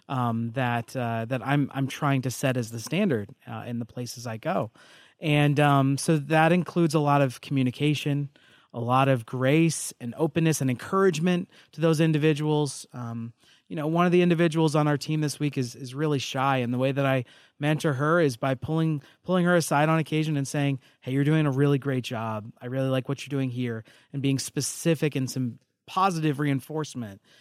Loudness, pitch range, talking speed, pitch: -26 LUFS, 130-155 Hz, 200 wpm, 140 Hz